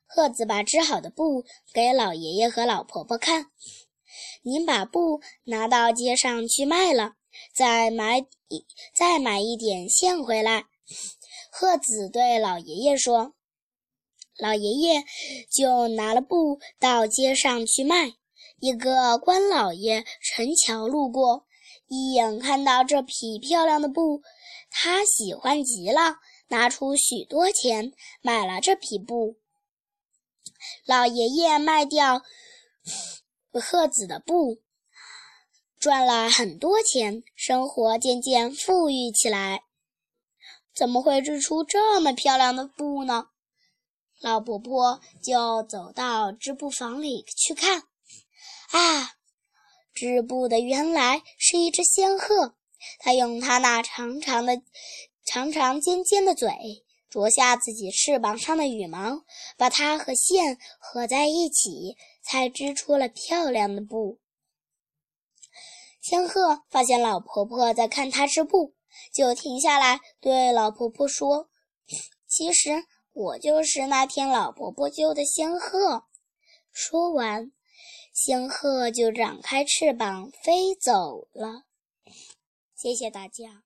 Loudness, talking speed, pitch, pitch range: -23 LUFS, 170 characters per minute, 265 Hz, 235-320 Hz